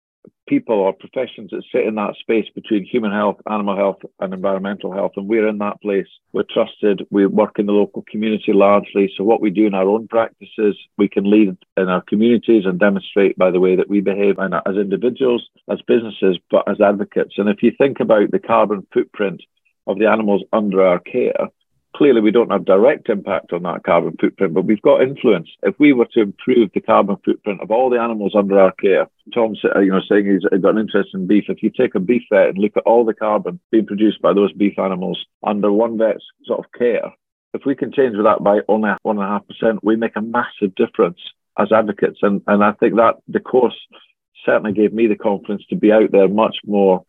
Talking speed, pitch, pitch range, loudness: 220 wpm, 105 Hz, 100-110 Hz, -17 LUFS